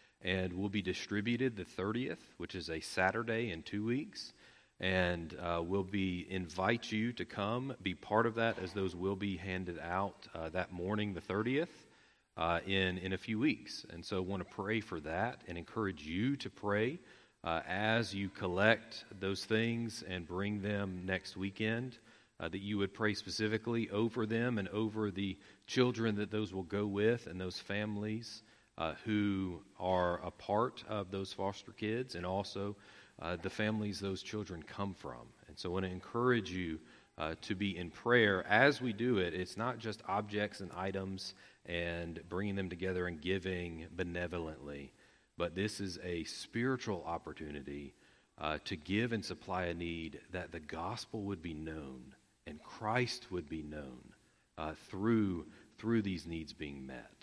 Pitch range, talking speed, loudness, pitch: 90-110 Hz, 170 wpm, -38 LUFS, 95 Hz